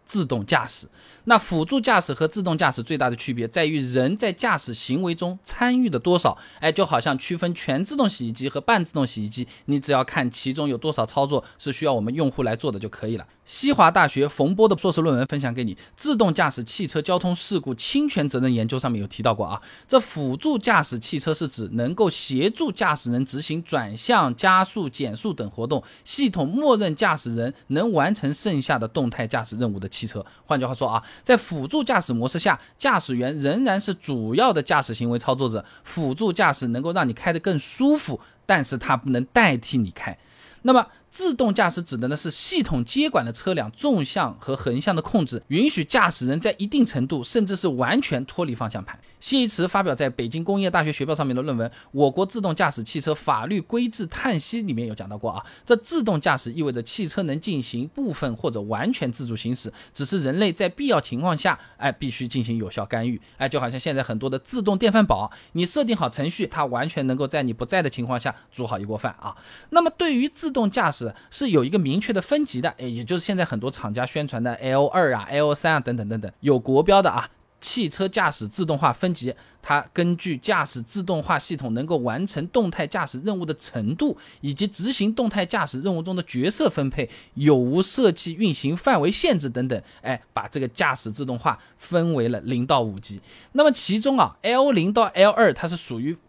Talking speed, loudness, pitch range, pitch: 320 characters per minute, -23 LUFS, 125-195 Hz, 150 Hz